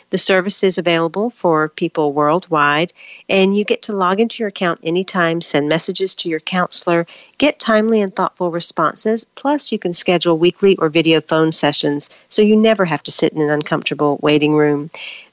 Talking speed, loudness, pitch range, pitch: 180 wpm, -16 LUFS, 160-195 Hz, 175 Hz